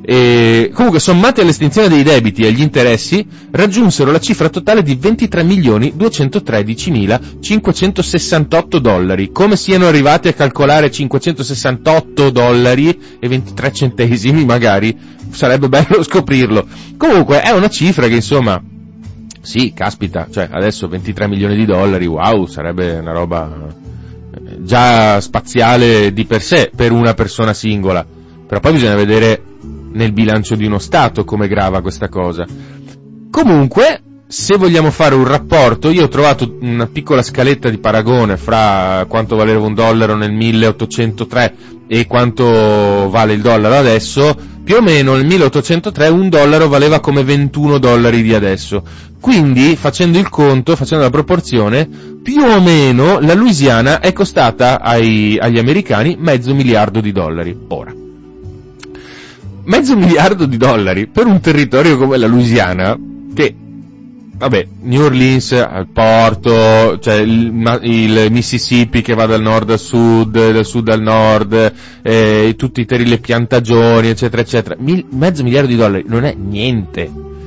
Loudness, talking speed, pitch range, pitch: -11 LUFS, 135 wpm, 105-145 Hz, 120 Hz